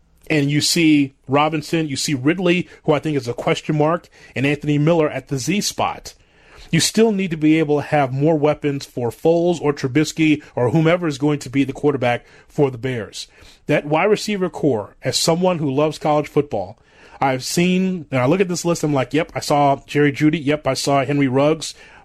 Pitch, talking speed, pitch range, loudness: 150 Hz, 205 wpm, 140-160 Hz, -19 LUFS